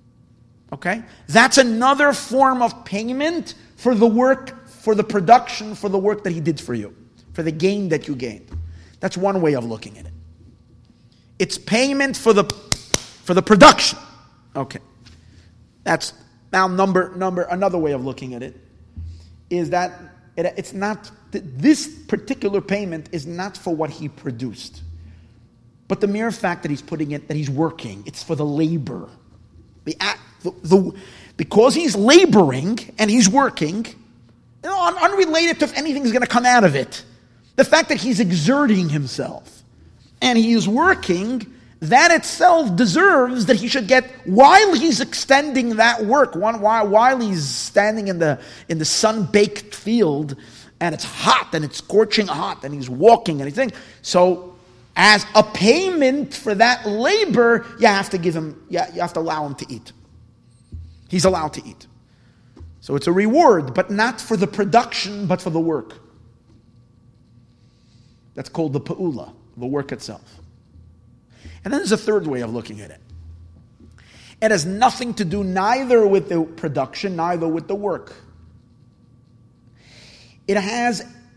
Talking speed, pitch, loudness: 160 wpm, 180 Hz, -18 LUFS